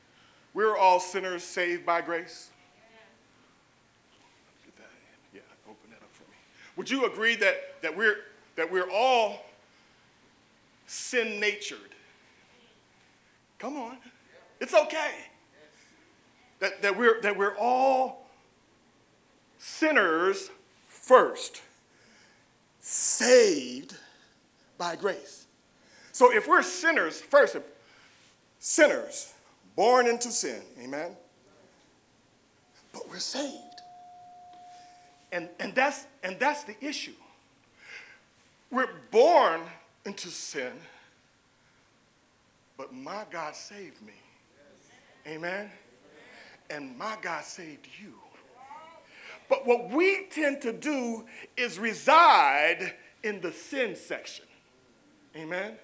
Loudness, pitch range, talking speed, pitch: -26 LUFS, 200-325 Hz, 95 wpm, 255 Hz